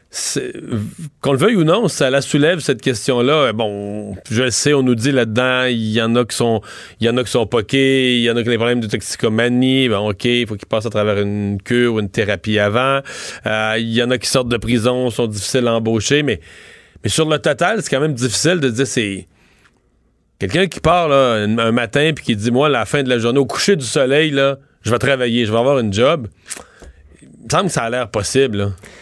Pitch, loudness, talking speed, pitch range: 120 Hz, -16 LUFS, 245 wpm, 110-135 Hz